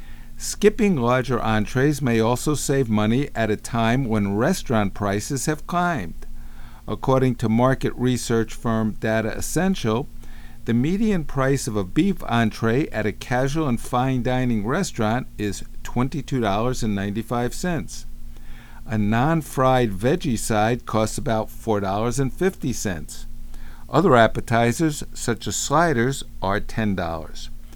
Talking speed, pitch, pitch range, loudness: 115 wpm, 120 Hz, 110-135 Hz, -22 LUFS